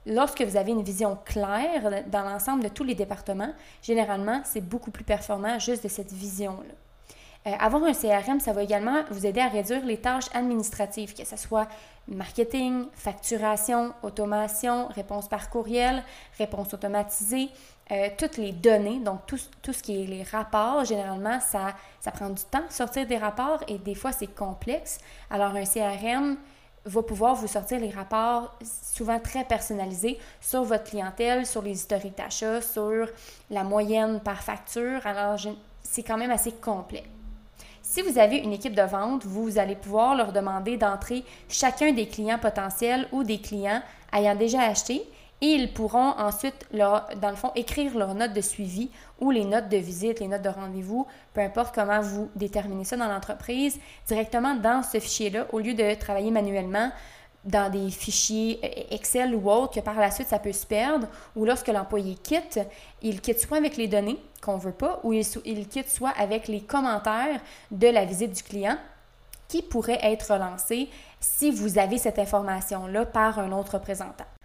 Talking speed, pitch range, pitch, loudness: 175 wpm, 205-245 Hz, 220 Hz, -27 LUFS